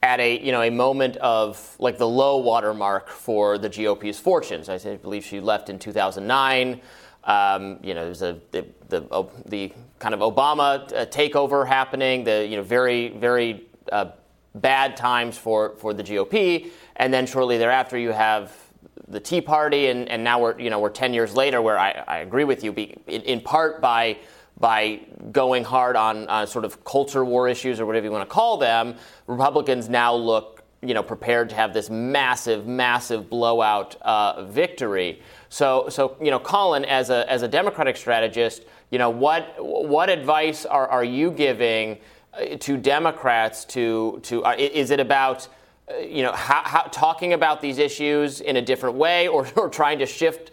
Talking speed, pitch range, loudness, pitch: 185 wpm, 110-135 Hz, -22 LUFS, 120 Hz